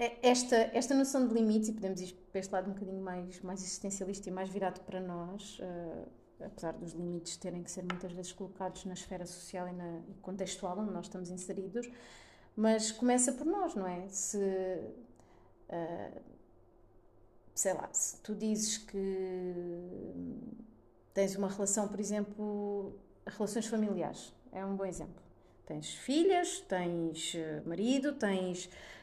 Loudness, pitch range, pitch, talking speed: -36 LUFS, 180-215 Hz, 190 Hz, 145 wpm